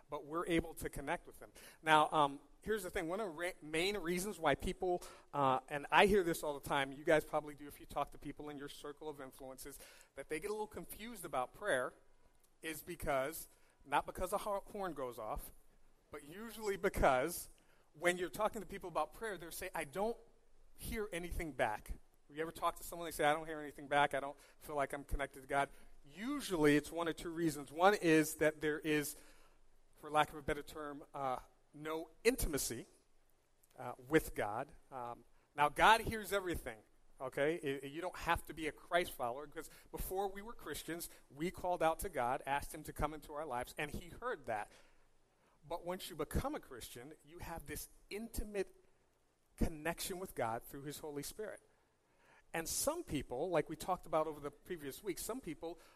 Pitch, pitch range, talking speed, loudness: 160 Hz, 145-180 Hz, 200 wpm, -39 LUFS